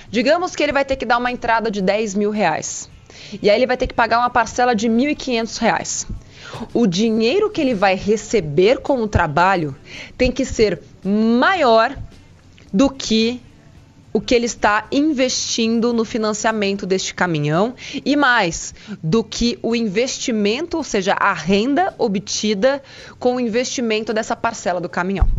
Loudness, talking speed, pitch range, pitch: -18 LUFS, 160 wpm, 200-250 Hz, 225 Hz